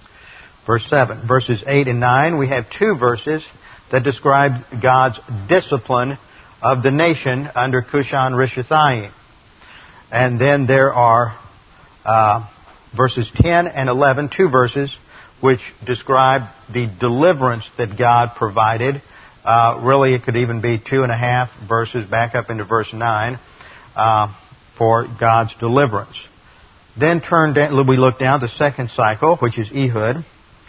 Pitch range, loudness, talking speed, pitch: 115-135 Hz, -16 LUFS, 135 wpm, 125 Hz